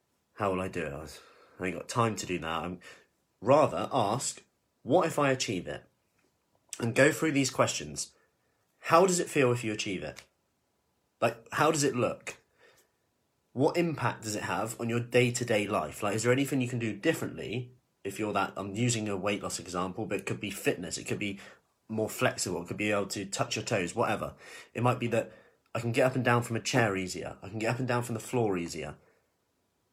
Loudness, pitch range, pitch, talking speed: -30 LUFS, 100-125 Hz, 115 Hz, 220 wpm